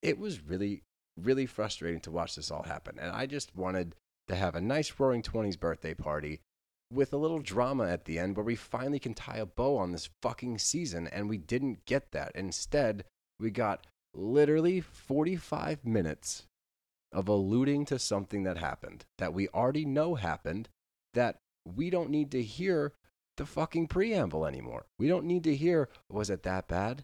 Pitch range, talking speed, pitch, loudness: 90-140 Hz, 180 wpm, 110 Hz, -33 LUFS